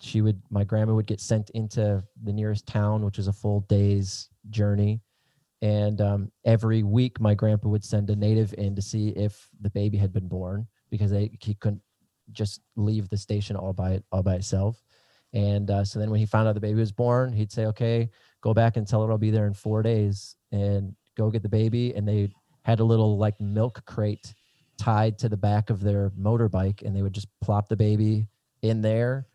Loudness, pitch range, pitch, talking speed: -26 LUFS, 100-110 Hz, 105 Hz, 215 wpm